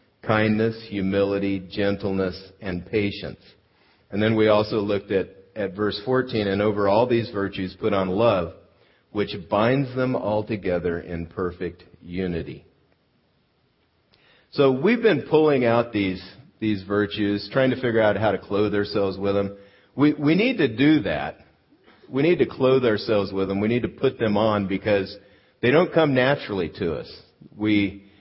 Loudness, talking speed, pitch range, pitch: -23 LUFS, 160 wpm, 100-120 Hz, 105 Hz